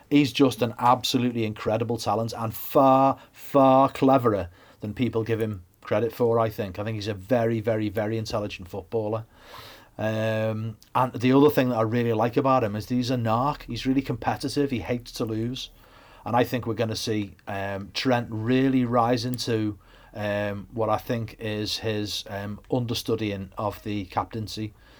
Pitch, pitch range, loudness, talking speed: 115 Hz, 105-125 Hz, -25 LUFS, 175 wpm